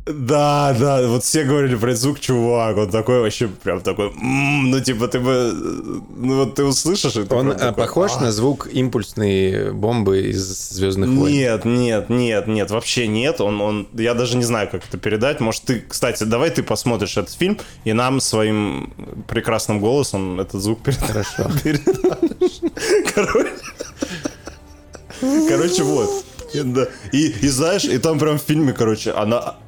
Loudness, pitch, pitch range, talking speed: -19 LUFS, 125 Hz, 110-140 Hz, 150 wpm